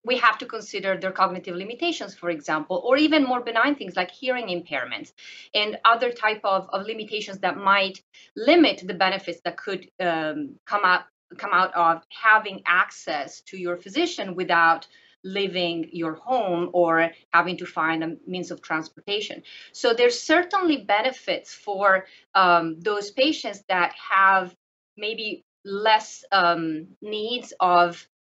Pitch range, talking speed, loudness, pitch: 175-225 Hz, 145 wpm, -23 LUFS, 195 Hz